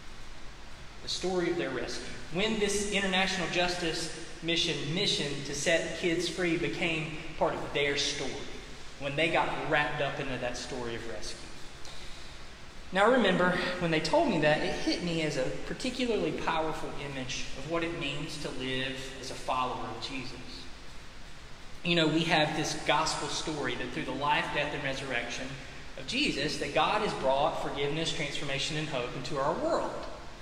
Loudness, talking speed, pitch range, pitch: -31 LUFS, 160 wpm, 130-165 Hz, 150 Hz